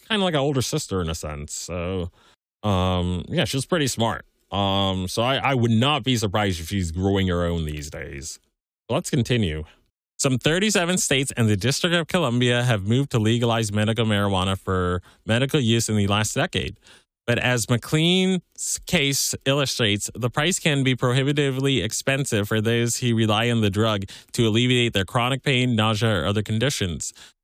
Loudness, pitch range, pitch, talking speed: -22 LUFS, 100-135 Hz, 115 Hz, 175 wpm